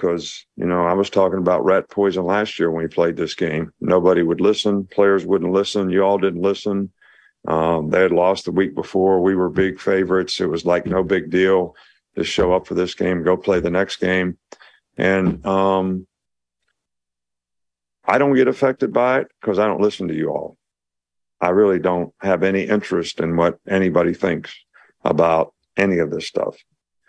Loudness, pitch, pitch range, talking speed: -19 LUFS, 95 Hz, 85-95 Hz, 185 wpm